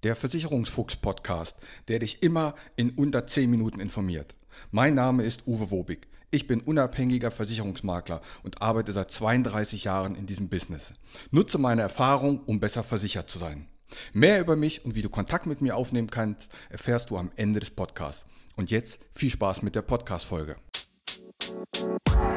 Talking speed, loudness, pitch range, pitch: 165 wpm, -28 LUFS, 100-125 Hz, 110 Hz